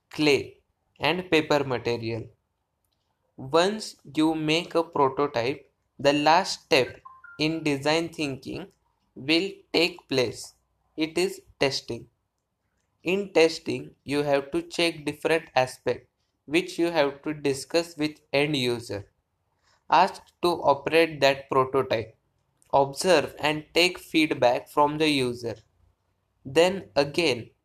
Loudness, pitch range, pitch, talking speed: -25 LUFS, 120-165 Hz, 145 Hz, 110 wpm